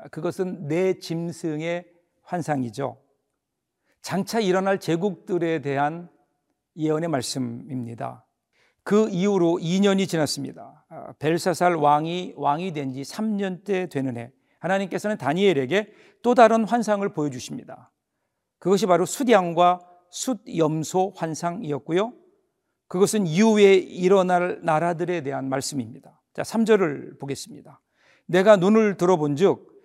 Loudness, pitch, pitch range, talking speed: -23 LUFS, 175 Hz, 150-200 Hz, 265 characters per minute